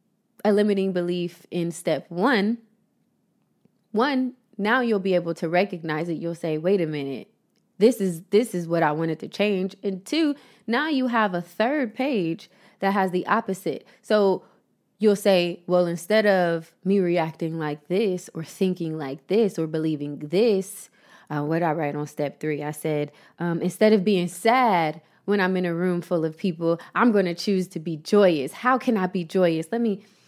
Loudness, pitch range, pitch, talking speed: -24 LUFS, 165-215 Hz, 185 Hz, 185 wpm